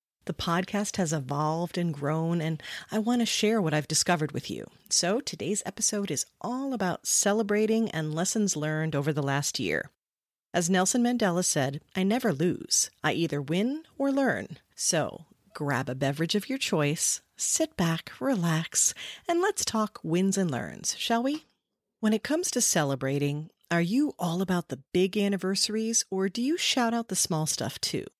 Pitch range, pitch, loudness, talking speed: 155-225 Hz, 185 Hz, -27 LUFS, 170 wpm